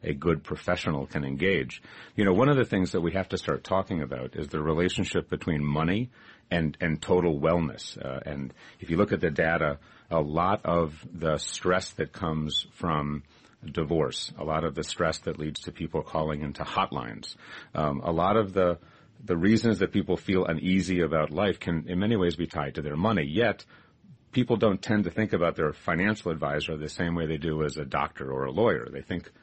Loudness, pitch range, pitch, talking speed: -28 LUFS, 75-95 Hz, 85 Hz, 205 wpm